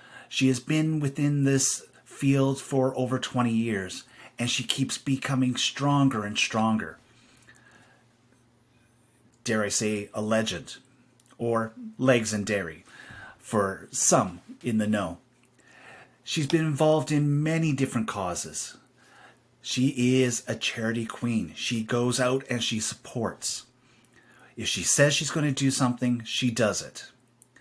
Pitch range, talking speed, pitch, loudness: 115-135 Hz, 130 wpm, 125 Hz, -26 LUFS